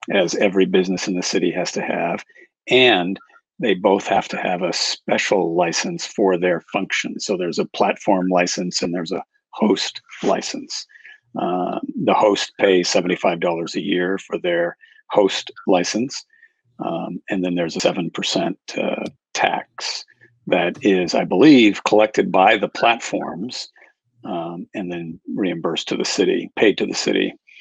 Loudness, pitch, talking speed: -19 LUFS, 105 Hz, 150 wpm